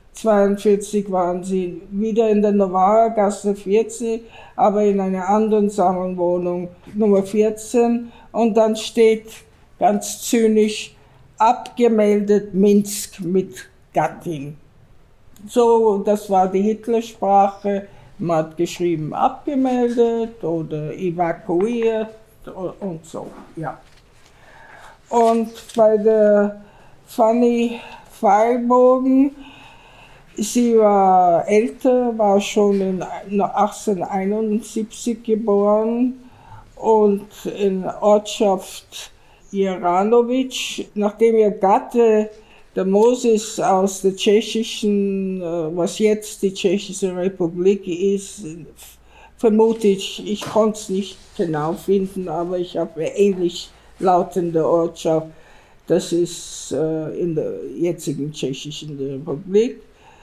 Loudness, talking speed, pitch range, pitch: -19 LUFS, 90 wpm, 185-220 Hz, 205 Hz